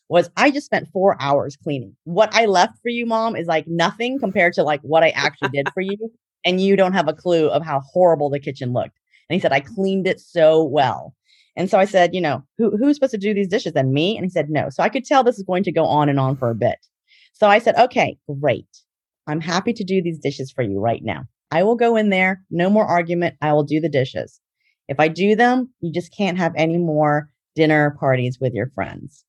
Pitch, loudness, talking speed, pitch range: 170 Hz, -19 LUFS, 250 wpm, 145-205 Hz